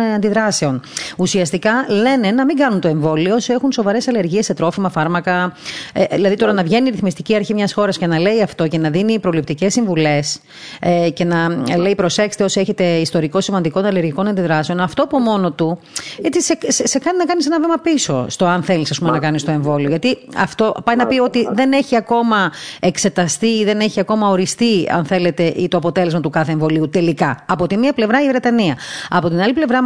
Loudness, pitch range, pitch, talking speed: -16 LUFS, 170-225 Hz, 195 Hz, 200 wpm